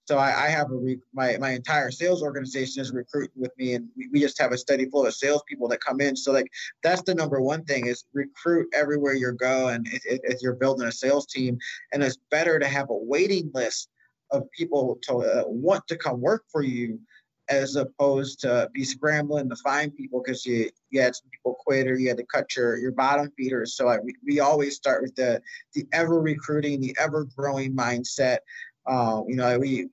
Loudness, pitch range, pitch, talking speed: -25 LUFS, 130-150 Hz, 135 Hz, 215 wpm